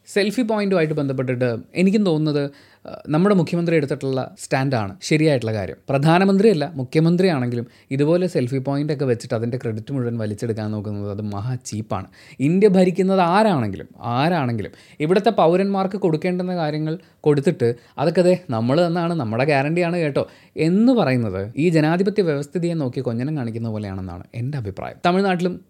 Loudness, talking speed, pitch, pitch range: -20 LUFS, 125 wpm, 145 Hz, 120-175 Hz